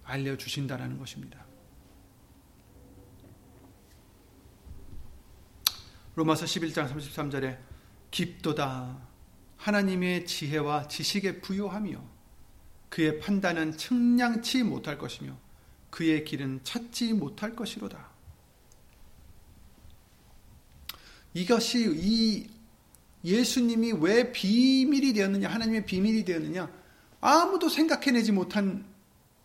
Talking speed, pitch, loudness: 195 characters per minute, 175 Hz, -28 LUFS